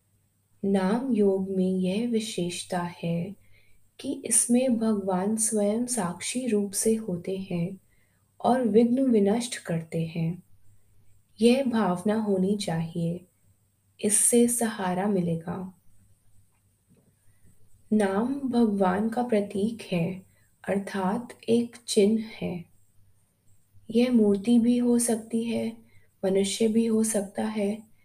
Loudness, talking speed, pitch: -26 LUFS, 100 wpm, 195 Hz